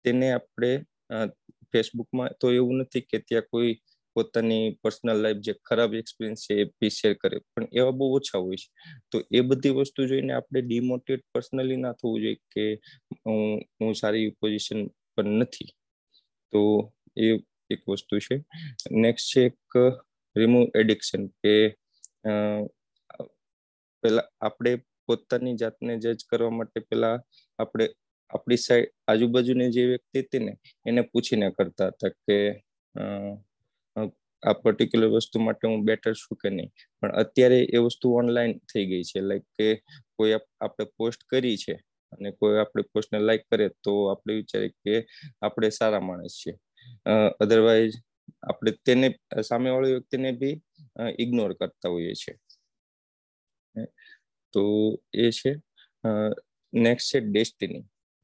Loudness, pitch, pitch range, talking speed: -26 LUFS, 115 Hz, 105-125 Hz, 135 wpm